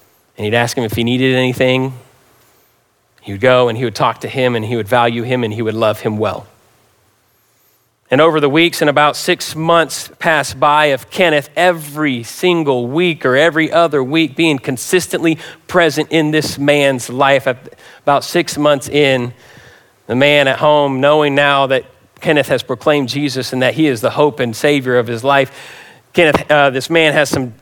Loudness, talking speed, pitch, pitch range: -14 LUFS, 185 wpm, 140 Hz, 125-150 Hz